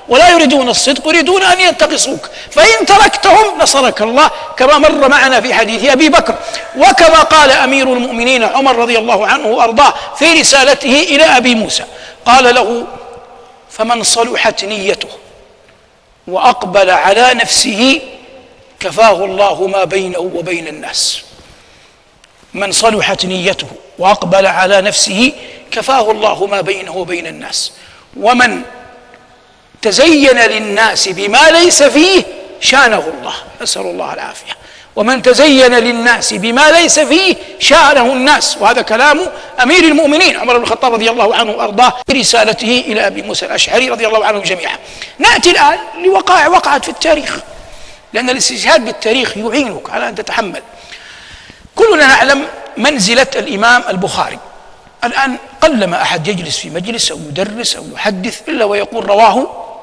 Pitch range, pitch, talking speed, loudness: 215-295 Hz, 250 Hz, 125 wpm, -9 LUFS